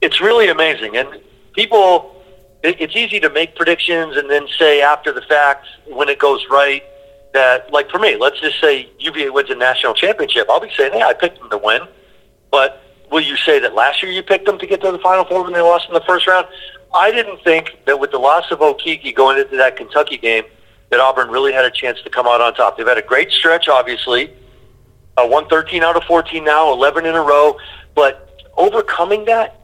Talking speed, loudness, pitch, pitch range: 220 wpm, -14 LUFS, 160 Hz, 140-185 Hz